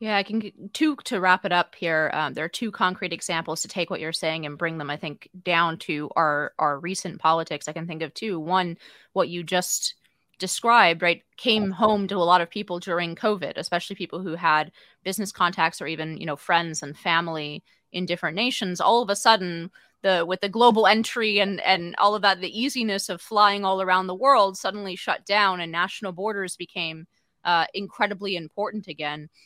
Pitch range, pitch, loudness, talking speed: 165-205 Hz, 185 Hz, -24 LUFS, 205 wpm